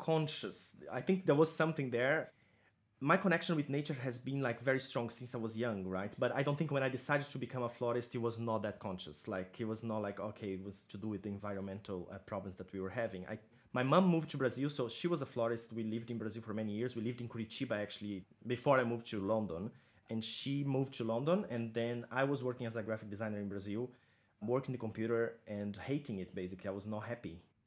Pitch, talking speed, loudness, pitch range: 115 Hz, 240 wpm, -38 LUFS, 105-130 Hz